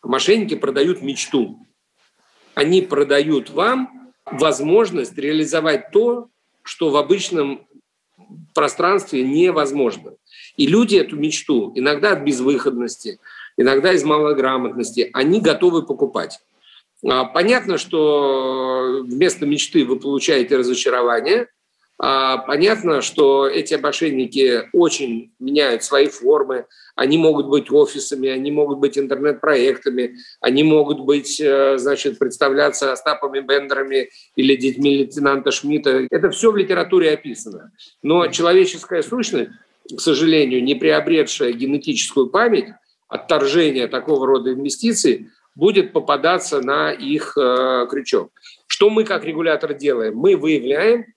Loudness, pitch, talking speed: -17 LUFS, 160 Hz, 105 wpm